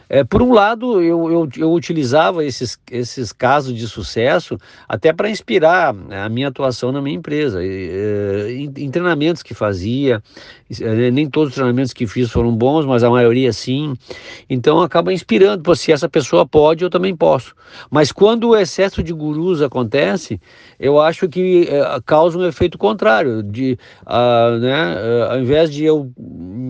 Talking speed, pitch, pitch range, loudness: 175 wpm, 145 Hz, 125-170 Hz, -15 LUFS